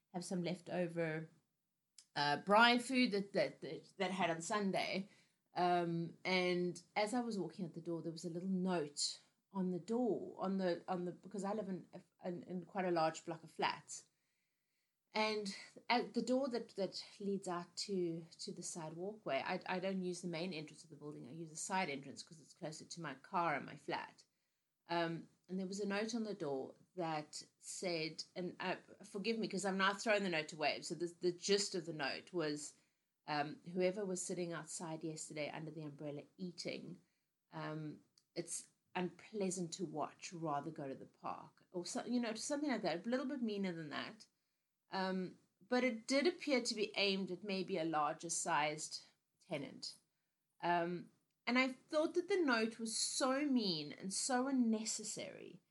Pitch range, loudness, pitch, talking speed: 165-205 Hz, -41 LUFS, 180 Hz, 185 wpm